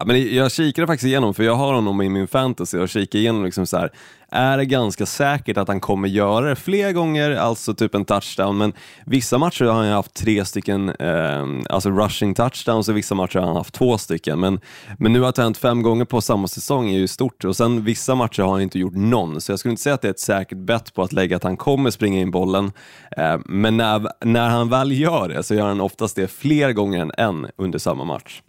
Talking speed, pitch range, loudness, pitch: 250 wpm, 95-125 Hz, -20 LUFS, 110 Hz